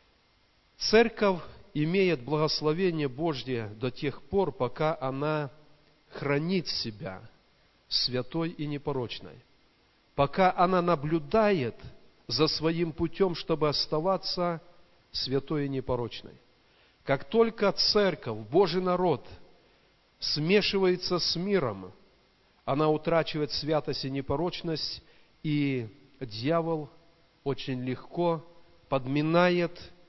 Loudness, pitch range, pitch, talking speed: -28 LUFS, 135-175 Hz, 155 Hz, 85 wpm